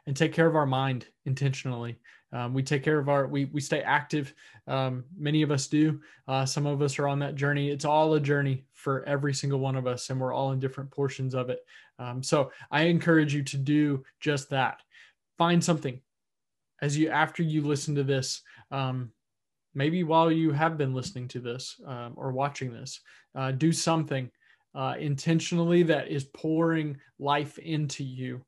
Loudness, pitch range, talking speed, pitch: -28 LUFS, 130-155 Hz, 190 wpm, 140 Hz